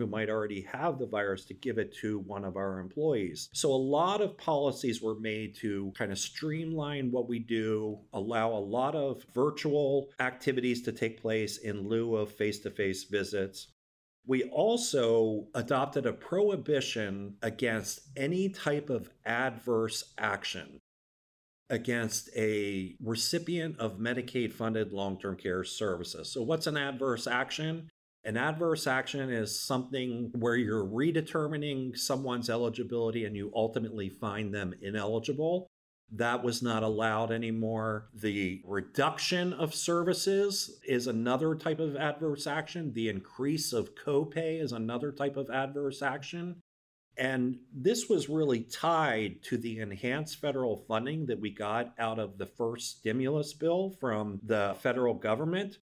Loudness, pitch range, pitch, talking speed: -32 LUFS, 110-145 Hz, 125 Hz, 145 wpm